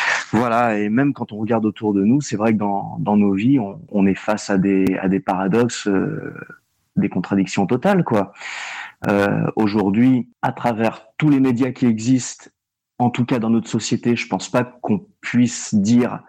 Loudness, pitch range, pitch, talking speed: -19 LUFS, 100-120 Hz, 115 Hz, 190 wpm